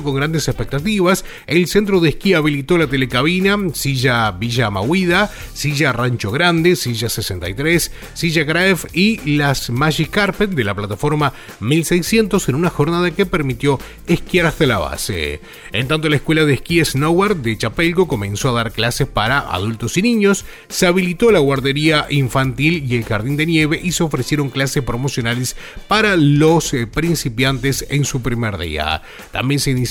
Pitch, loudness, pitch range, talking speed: 145 Hz, -16 LUFS, 125-170 Hz, 160 wpm